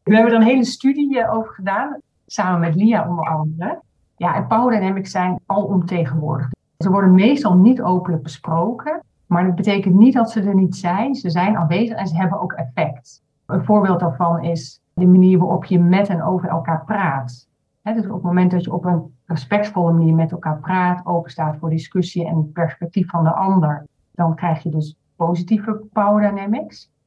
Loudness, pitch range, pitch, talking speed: -18 LUFS, 165-205 Hz, 180 Hz, 185 wpm